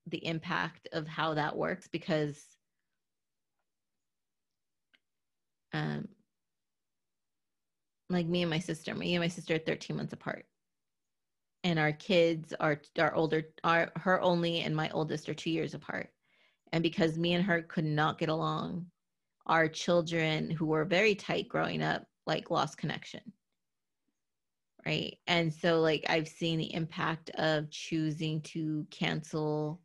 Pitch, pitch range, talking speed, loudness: 160 Hz, 155-170 Hz, 140 wpm, -32 LUFS